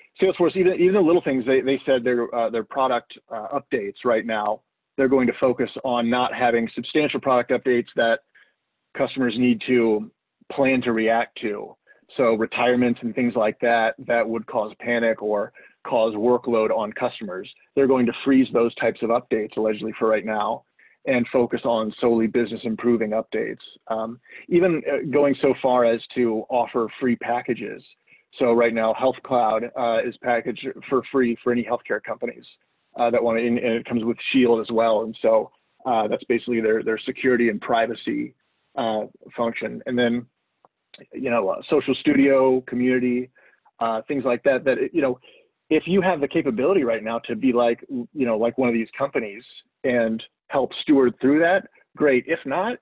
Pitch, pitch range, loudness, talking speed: 120 Hz, 115-130 Hz, -22 LUFS, 180 wpm